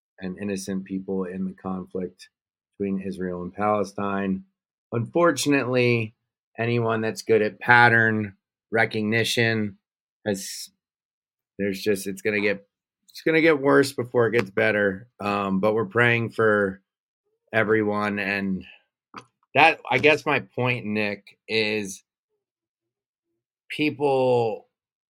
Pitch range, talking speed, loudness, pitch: 100-120 Hz, 115 wpm, -23 LUFS, 110 Hz